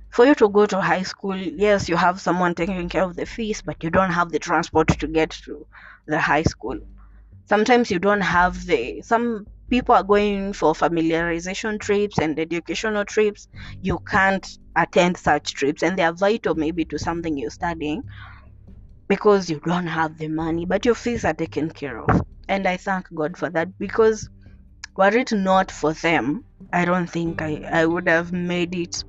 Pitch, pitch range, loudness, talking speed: 175 Hz, 160-200 Hz, -21 LUFS, 190 wpm